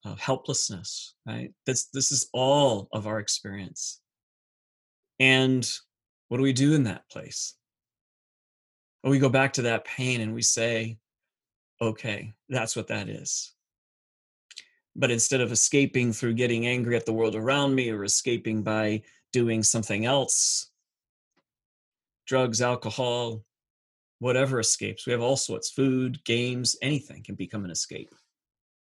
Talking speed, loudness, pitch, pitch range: 135 wpm, -26 LUFS, 120 Hz, 110-130 Hz